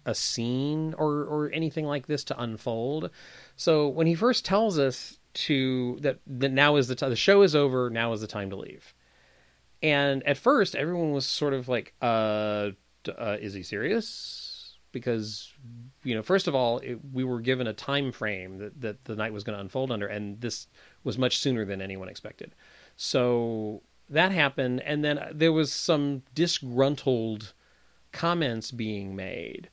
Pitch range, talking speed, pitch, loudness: 110-145 Hz, 175 wpm, 130 Hz, -27 LUFS